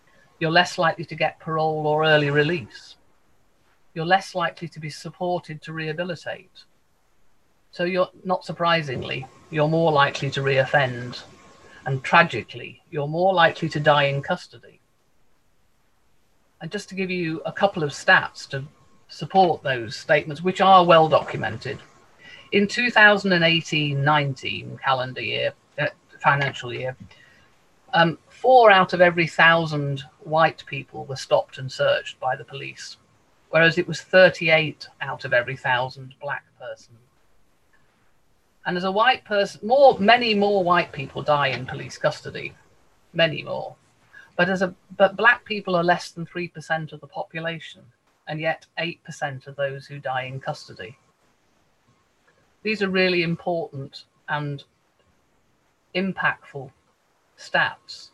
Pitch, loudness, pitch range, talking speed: 165 Hz, -21 LUFS, 145-185 Hz, 135 wpm